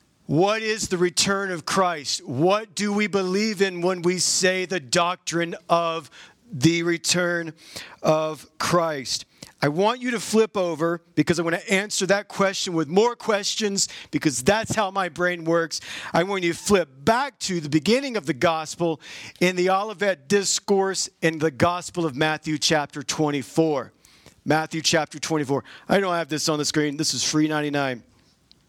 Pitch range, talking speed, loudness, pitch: 155-195 Hz, 165 wpm, -23 LUFS, 170 Hz